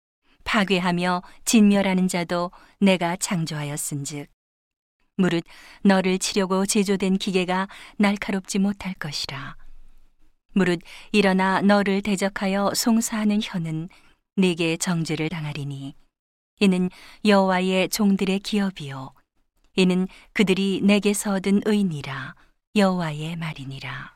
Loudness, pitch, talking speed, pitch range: -23 LUFS, 190 Hz, 245 characters per minute, 170-200 Hz